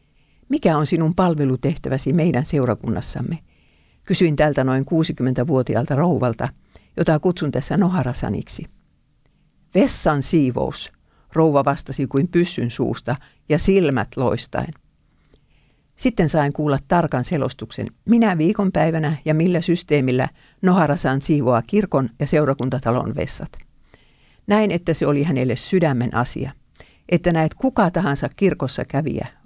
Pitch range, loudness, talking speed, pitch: 130-170 Hz, -20 LUFS, 110 wpm, 150 Hz